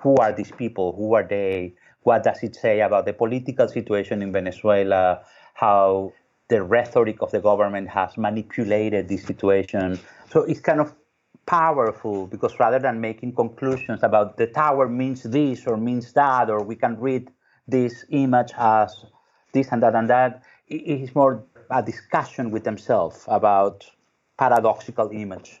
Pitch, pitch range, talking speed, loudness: 110 Hz, 100-130 Hz, 155 wpm, -22 LUFS